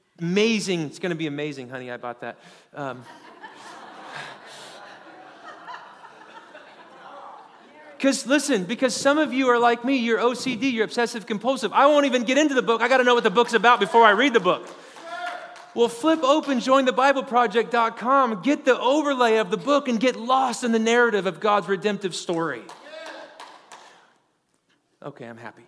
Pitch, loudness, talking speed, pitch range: 240 Hz, -21 LUFS, 155 wpm, 210-275 Hz